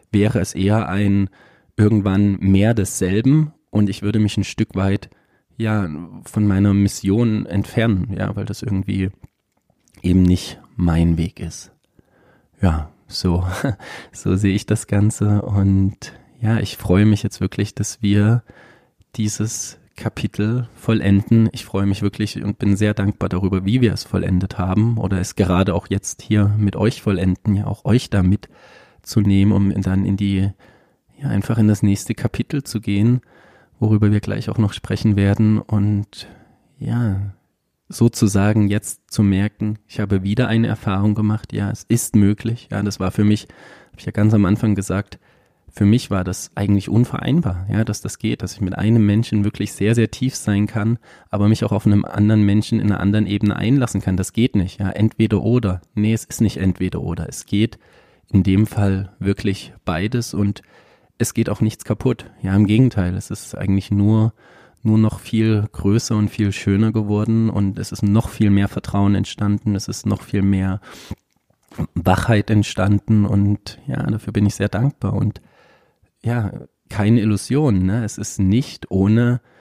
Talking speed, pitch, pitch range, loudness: 170 wpm, 105 Hz, 100-110 Hz, -19 LUFS